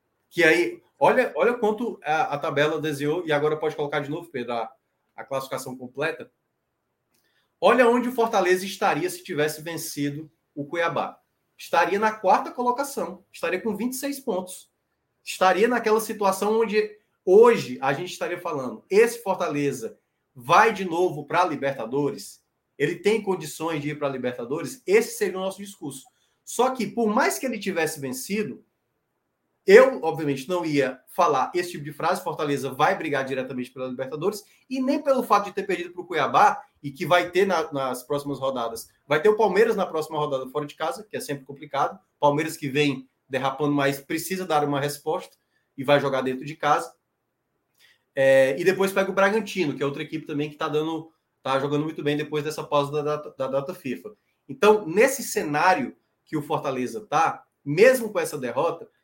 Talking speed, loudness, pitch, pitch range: 175 wpm, -24 LUFS, 160 Hz, 145-210 Hz